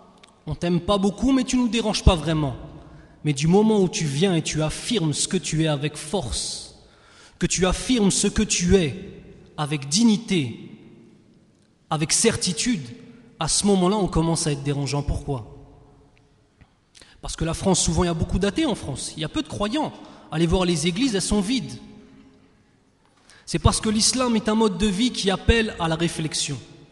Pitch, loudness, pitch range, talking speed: 180 Hz, -22 LUFS, 155-210 Hz, 190 wpm